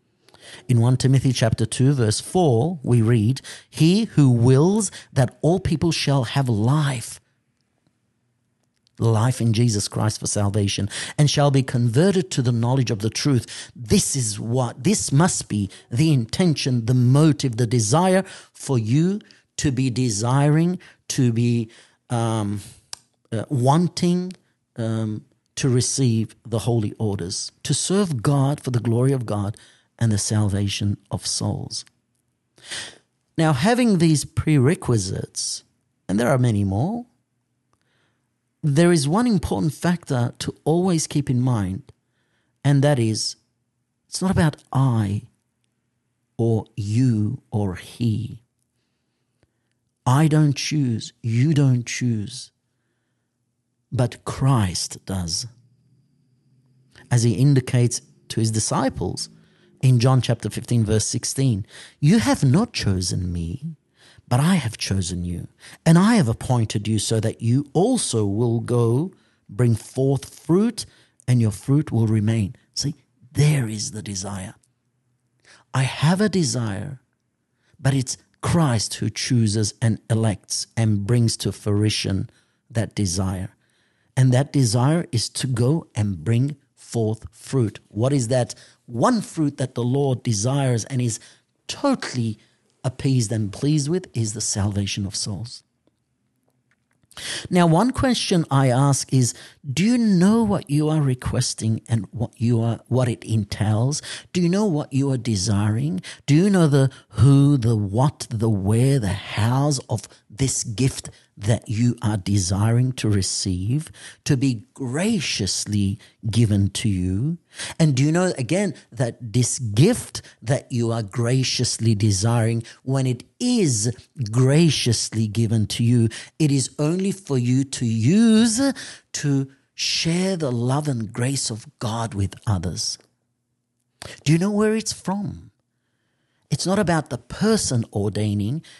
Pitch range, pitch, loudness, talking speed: 115-140 Hz, 125 Hz, -21 LUFS, 135 wpm